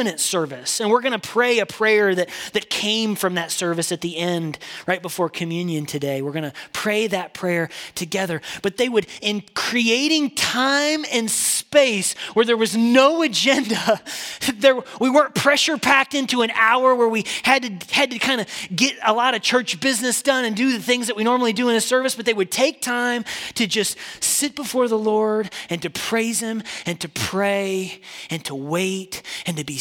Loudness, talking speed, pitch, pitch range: -20 LUFS, 200 wpm, 220 Hz, 180-250 Hz